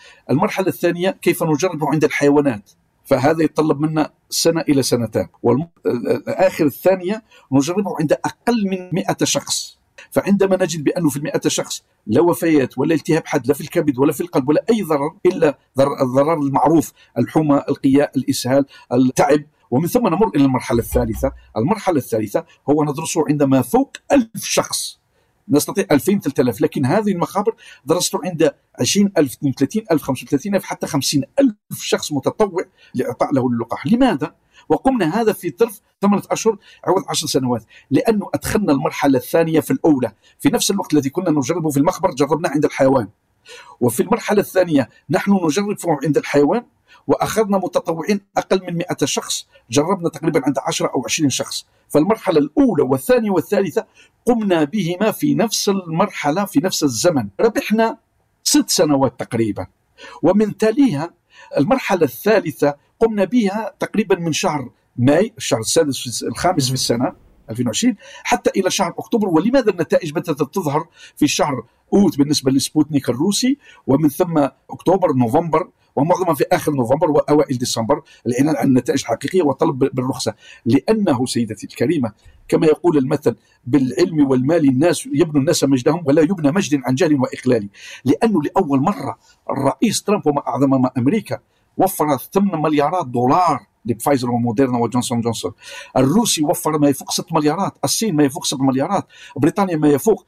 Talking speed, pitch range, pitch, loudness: 140 wpm, 140-195 Hz, 160 Hz, -18 LUFS